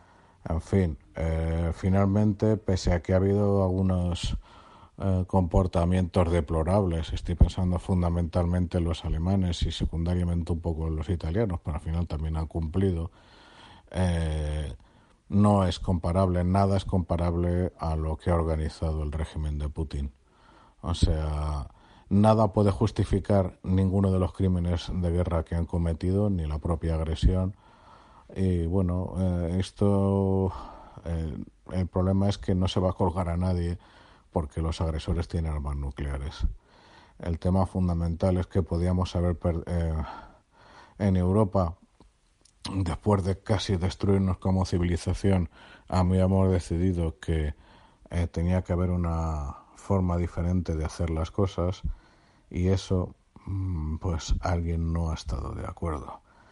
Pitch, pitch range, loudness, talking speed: 90 Hz, 80-95 Hz, -28 LUFS, 140 wpm